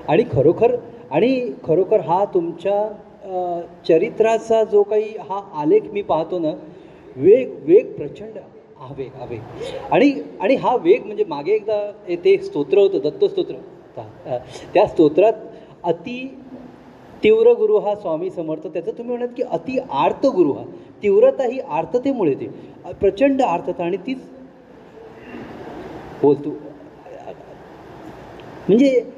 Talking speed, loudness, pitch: 115 wpm, -19 LUFS, 250 Hz